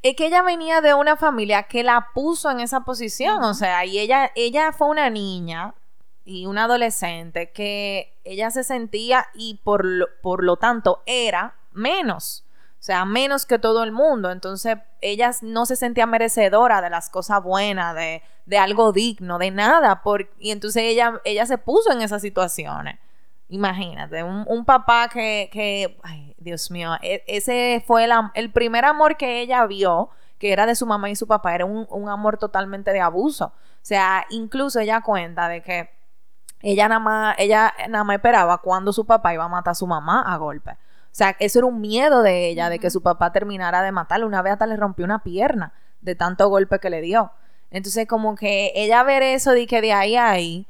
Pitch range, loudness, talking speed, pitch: 185-235 Hz, -20 LUFS, 200 wpm, 210 Hz